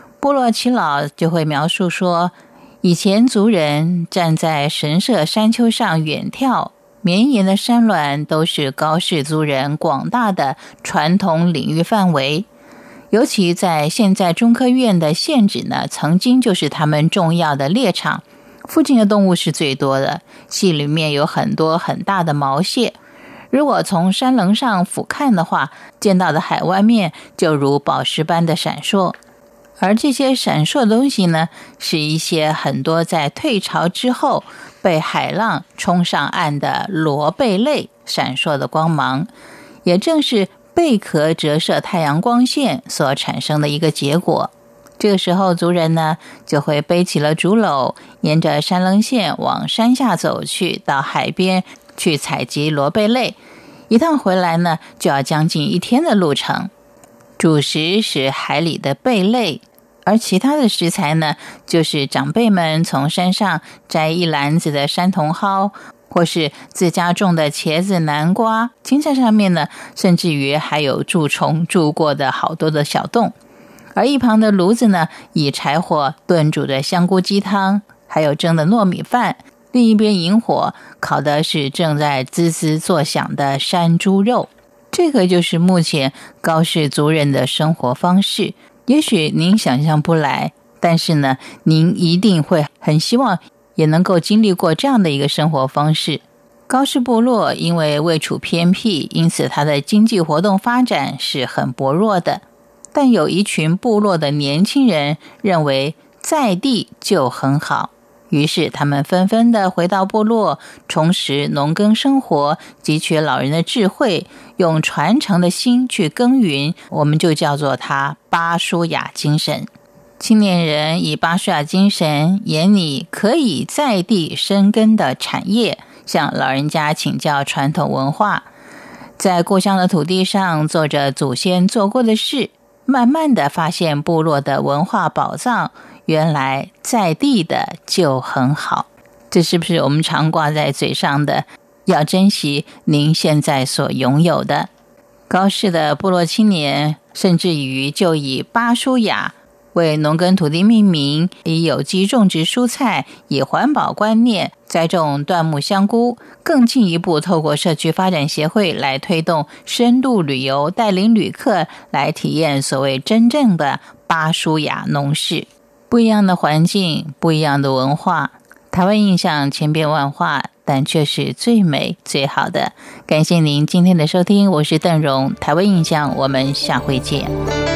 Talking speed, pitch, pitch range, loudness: 220 characters per minute, 170 Hz, 150-205 Hz, -16 LUFS